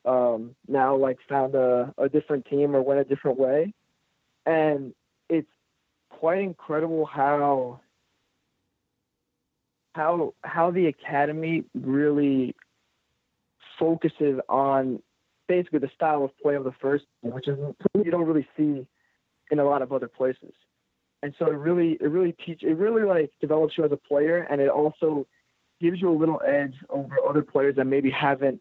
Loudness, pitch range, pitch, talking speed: -25 LUFS, 135-160 Hz, 145 Hz, 155 wpm